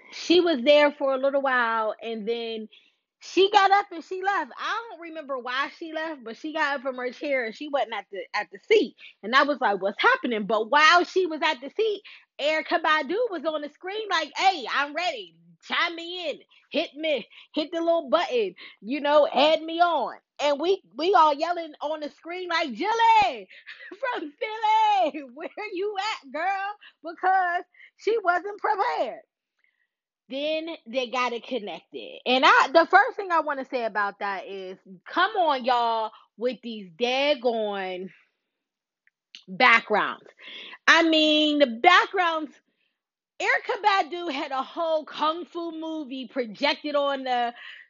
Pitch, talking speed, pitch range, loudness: 310 Hz, 165 wpm, 255-360 Hz, -24 LUFS